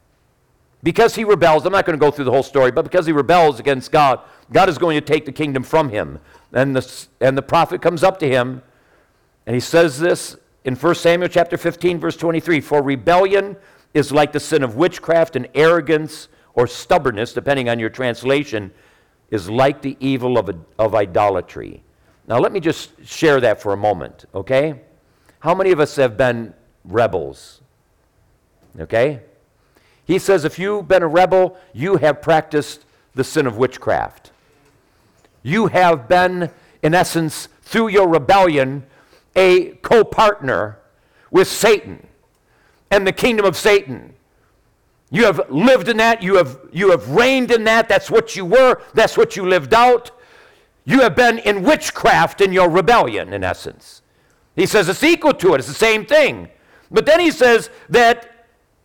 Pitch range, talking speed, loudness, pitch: 135-195 Hz, 170 wpm, -16 LUFS, 165 Hz